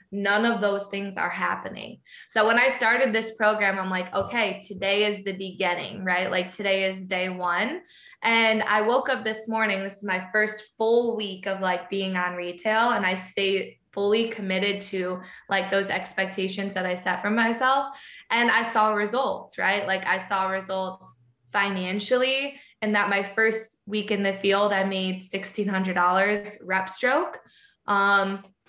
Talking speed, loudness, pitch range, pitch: 165 wpm, -25 LUFS, 190-220 Hz, 200 Hz